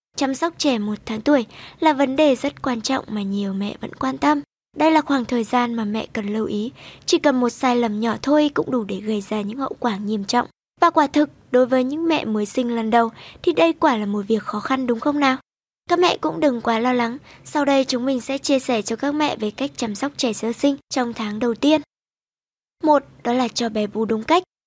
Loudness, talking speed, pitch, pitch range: -20 LUFS, 250 wpm, 255 Hz, 225-285 Hz